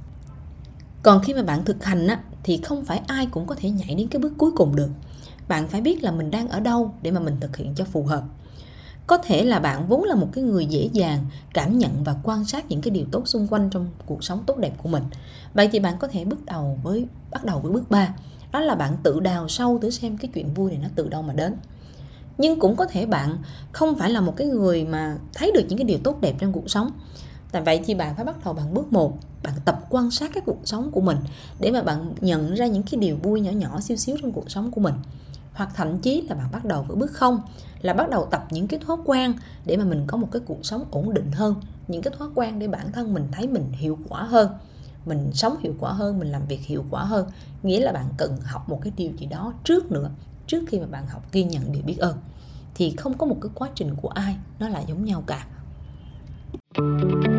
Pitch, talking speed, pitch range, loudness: 190 Hz, 255 wpm, 155-230 Hz, -24 LUFS